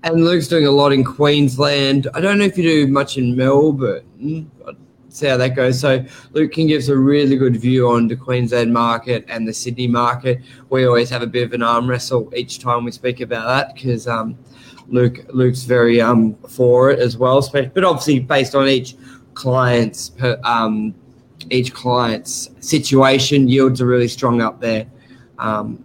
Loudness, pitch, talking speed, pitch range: -16 LUFS, 125 Hz, 185 wpm, 120-135 Hz